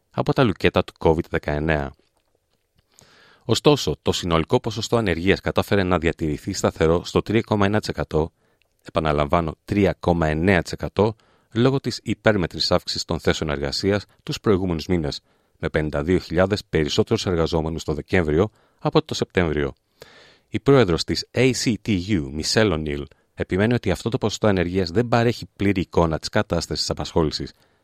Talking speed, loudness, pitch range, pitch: 125 wpm, -22 LUFS, 80-110 Hz, 90 Hz